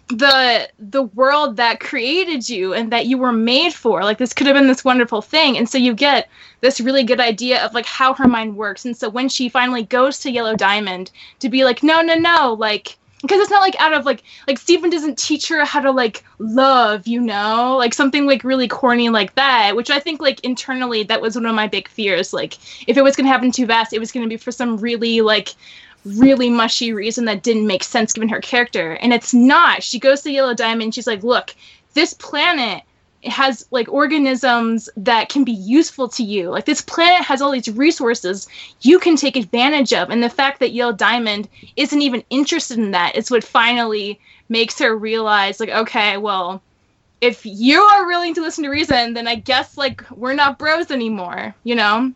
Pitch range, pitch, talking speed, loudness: 225-275 Hz, 245 Hz, 215 wpm, -16 LUFS